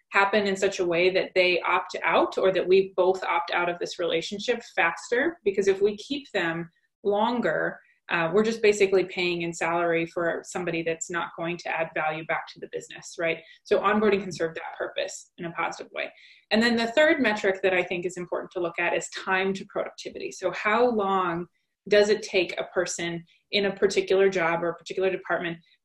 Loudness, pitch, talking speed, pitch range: -25 LUFS, 190 Hz, 205 wpm, 170-210 Hz